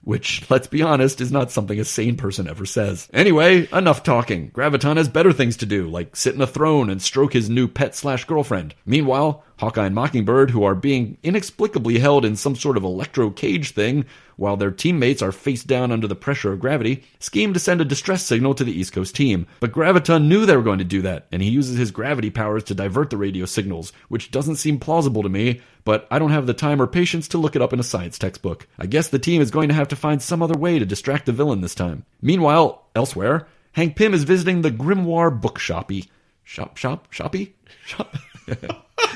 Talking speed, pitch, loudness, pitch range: 225 wpm, 130 Hz, -20 LUFS, 105-155 Hz